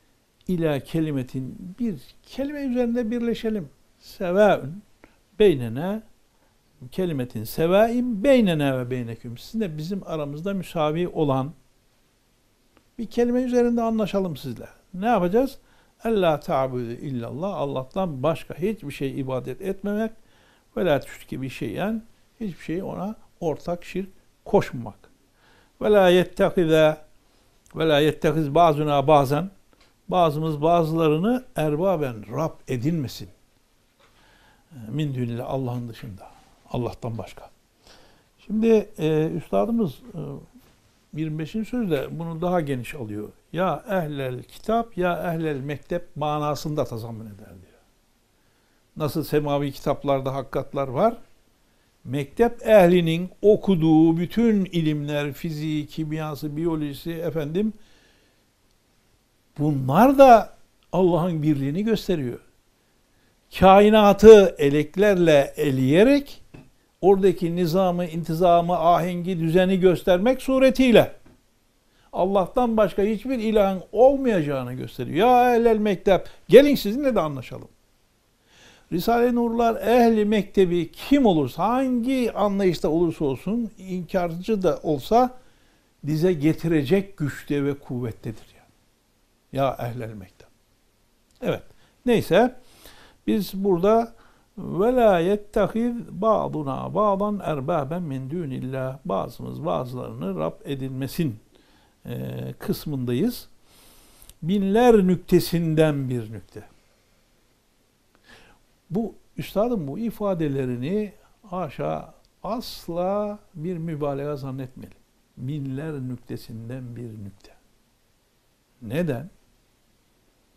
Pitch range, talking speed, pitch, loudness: 135-205 Hz, 90 wpm, 165 Hz, -22 LUFS